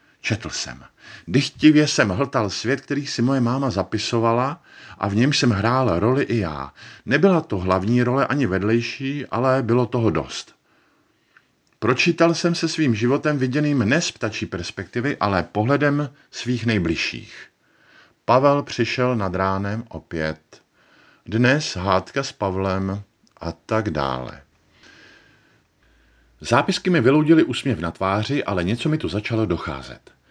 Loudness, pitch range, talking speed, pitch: -21 LUFS, 95-135 Hz, 135 wpm, 120 Hz